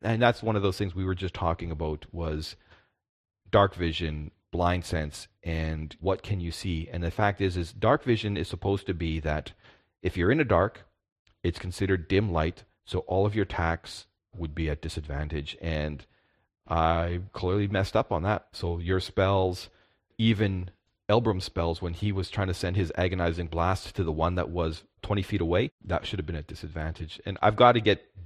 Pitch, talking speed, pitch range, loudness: 90 Hz, 195 wpm, 85-100 Hz, -28 LUFS